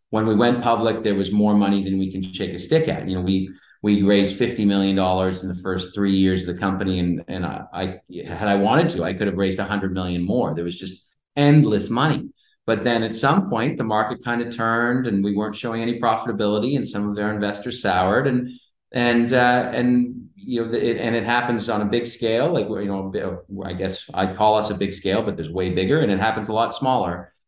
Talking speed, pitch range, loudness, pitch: 240 wpm, 95-120 Hz, -21 LUFS, 105 Hz